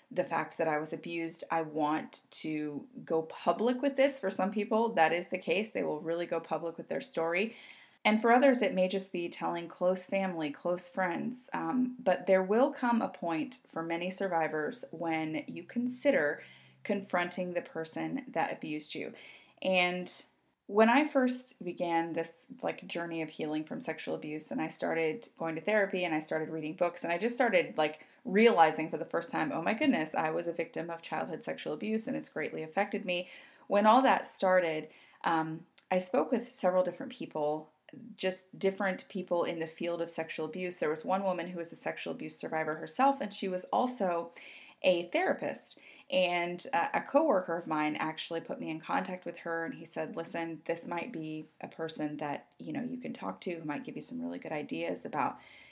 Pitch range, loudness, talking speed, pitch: 160-210 Hz, -33 LUFS, 200 wpm, 175 Hz